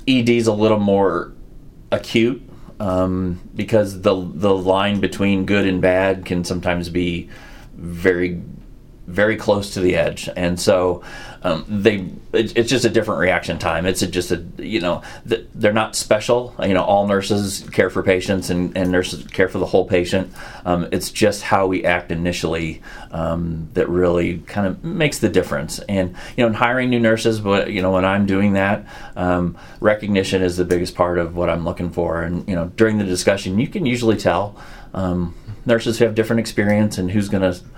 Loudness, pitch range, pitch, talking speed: -19 LUFS, 90-105 Hz, 95 Hz, 190 wpm